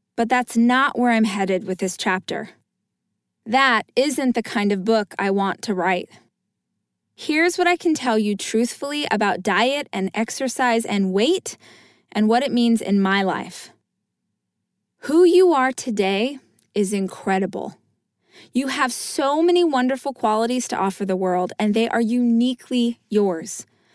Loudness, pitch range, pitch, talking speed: -20 LUFS, 200-265 Hz, 230 Hz, 150 wpm